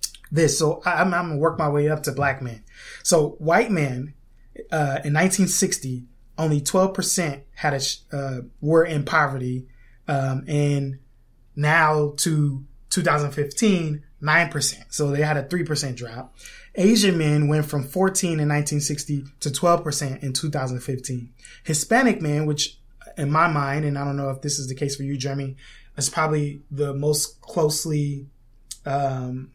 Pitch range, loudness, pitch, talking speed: 135-155 Hz, -22 LUFS, 145 Hz, 150 wpm